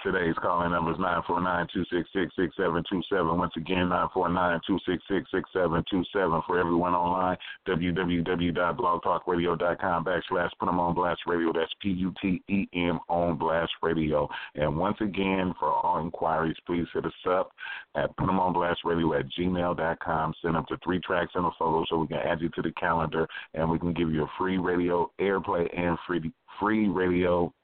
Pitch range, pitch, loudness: 85-90 Hz, 85 Hz, -28 LUFS